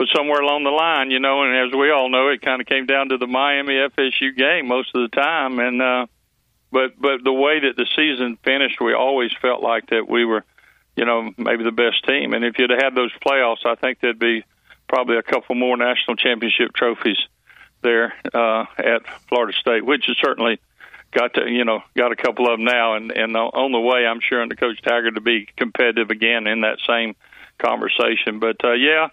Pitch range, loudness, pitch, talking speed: 115-135 Hz, -18 LUFS, 125 Hz, 220 wpm